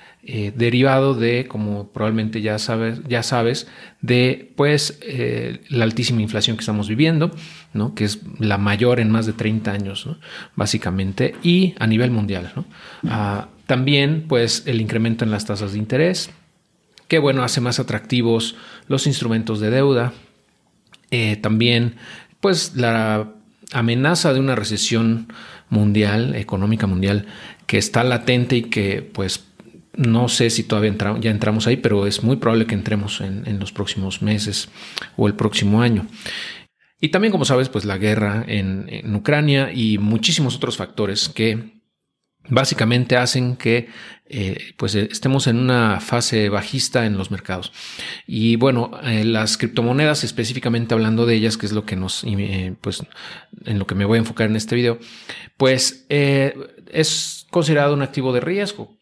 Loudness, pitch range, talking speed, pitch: -19 LUFS, 105-130 Hz, 160 wpm, 115 Hz